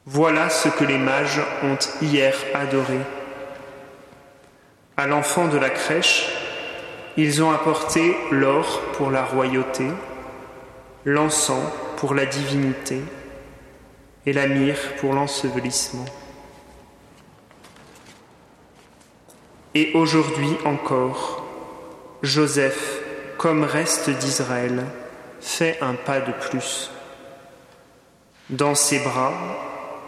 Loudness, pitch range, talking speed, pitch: -21 LUFS, 135-150 Hz, 90 wpm, 140 Hz